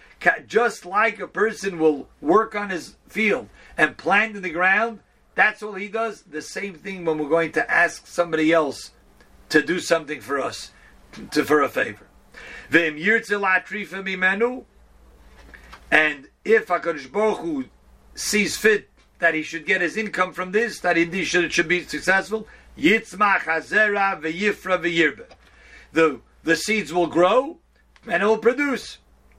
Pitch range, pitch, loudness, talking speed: 160-215 Hz, 185 Hz, -21 LUFS, 135 wpm